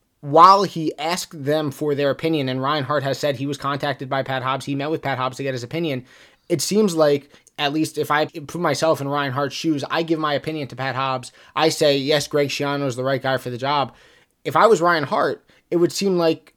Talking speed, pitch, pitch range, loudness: 245 wpm, 145 Hz, 135-160 Hz, -21 LUFS